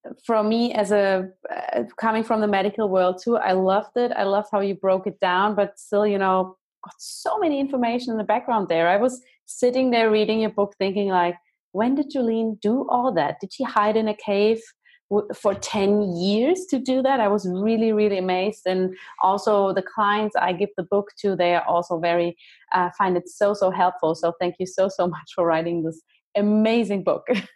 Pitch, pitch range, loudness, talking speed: 205 Hz, 185-225 Hz, -22 LUFS, 210 wpm